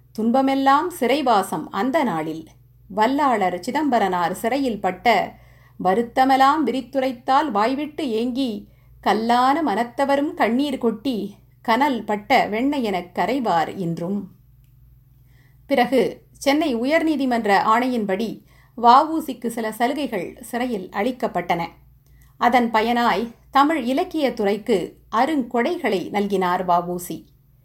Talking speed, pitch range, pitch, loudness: 80 wpm, 180-265 Hz, 230 Hz, -21 LUFS